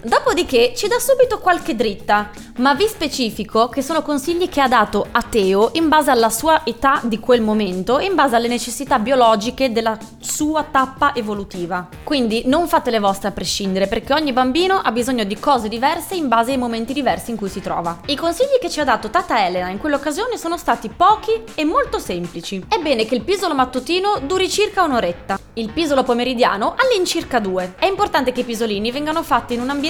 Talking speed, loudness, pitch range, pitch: 195 wpm, -18 LUFS, 225-330 Hz, 265 Hz